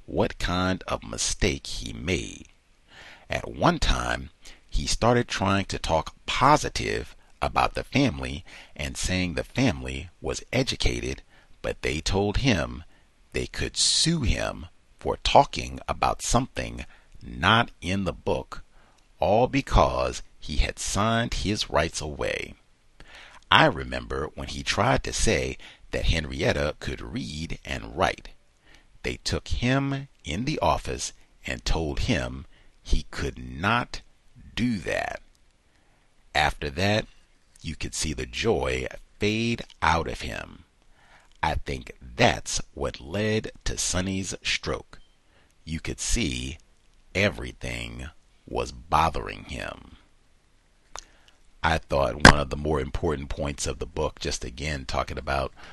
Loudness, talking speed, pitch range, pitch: -26 LUFS, 125 wpm, 70-100 Hz, 80 Hz